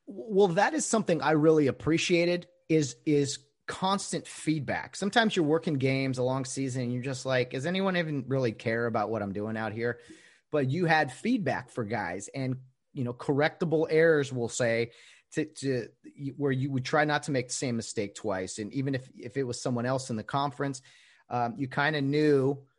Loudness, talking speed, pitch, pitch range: -29 LUFS, 200 wpm, 140 Hz, 125-155 Hz